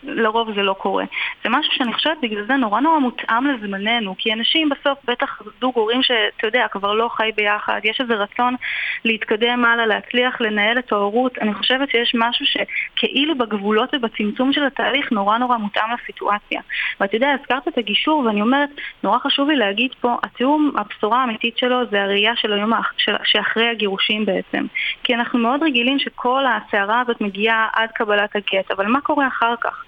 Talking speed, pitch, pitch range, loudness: 175 wpm, 235 Hz, 215-265 Hz, -18 LUFS